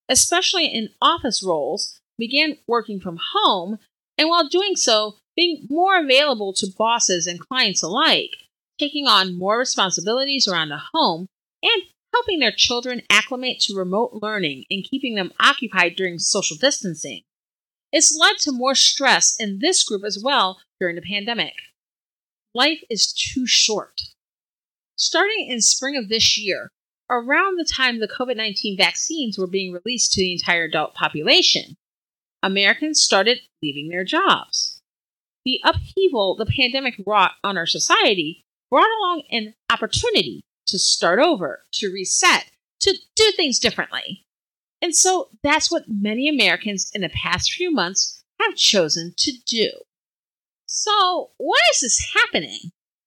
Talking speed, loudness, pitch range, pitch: 140 wpm, -18 LUFS, 195-315 Hz, 240 Hz